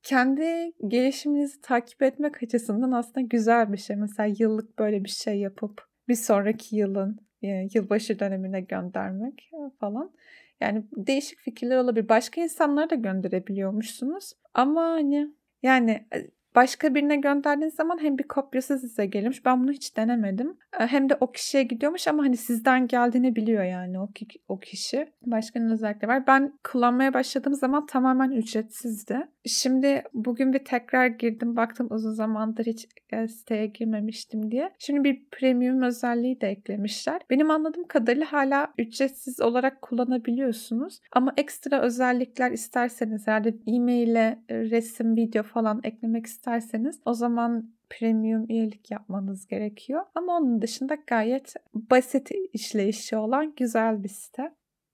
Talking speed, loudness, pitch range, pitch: 135 wpm, -26 LUFS, 220-275 Hz, 245 Hz